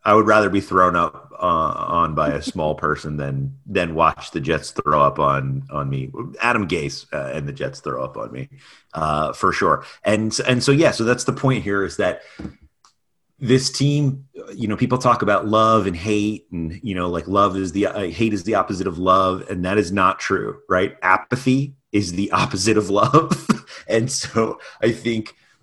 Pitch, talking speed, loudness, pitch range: 105 Hz, 200 wpm, -20 LUFS, 90-120 Hz